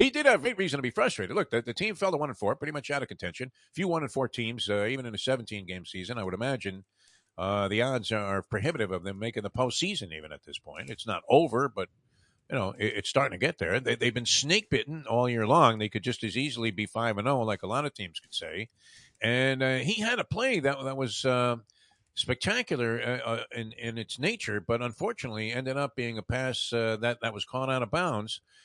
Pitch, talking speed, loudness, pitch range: 120 Hz, 250 wpm, -29 LUFS, 110-135 Hz